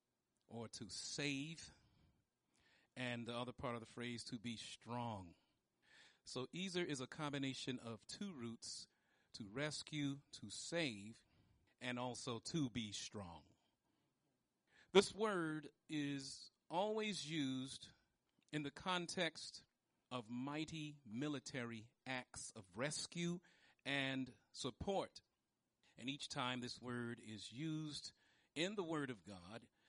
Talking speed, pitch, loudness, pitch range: 115 wpm, 130 Hz, -46 LUFS, 120-155 Hz